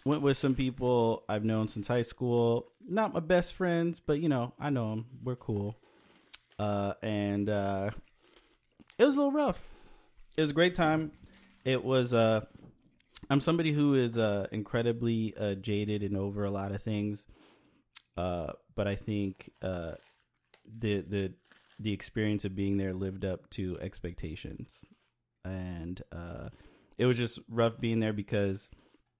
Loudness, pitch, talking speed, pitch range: -32 LUFS, 110 Hz, 155 wpm, 100-130 Hz